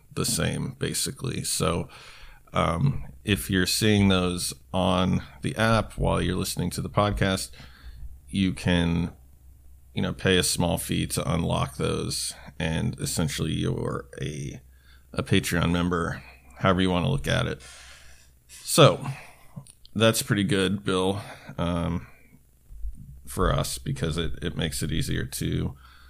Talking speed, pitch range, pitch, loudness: 135 wpm, 65-95 Hz, 85 Hz, -26 LUFS